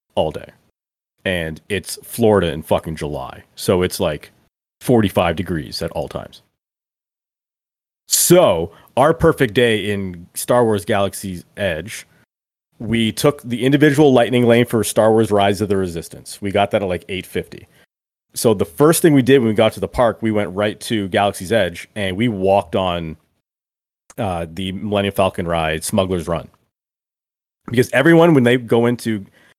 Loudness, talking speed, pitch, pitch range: -17 LUFS, 160 wpm, 105 Hz, 95-120 Hz